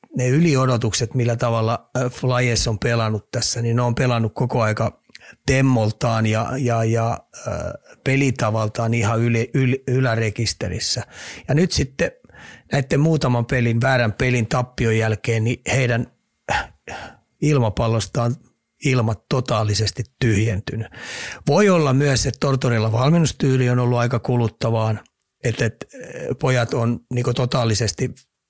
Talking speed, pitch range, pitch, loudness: 110 wpm, 115-130 Hz, 120 Hz, -20 LUFS